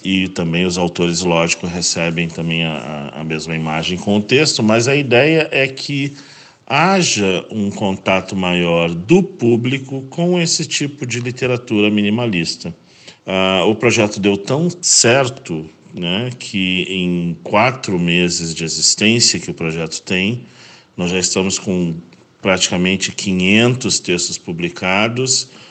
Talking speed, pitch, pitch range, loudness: 130 wpm, 95 Hz, 85-125 Hz, -15 LUFS